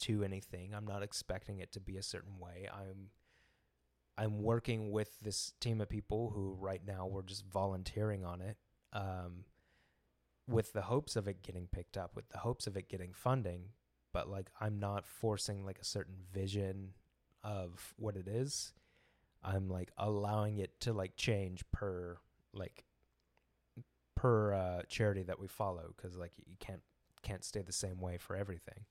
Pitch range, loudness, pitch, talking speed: 90-105 Hz, -41 LUFS, 95 Hz, 170 wpm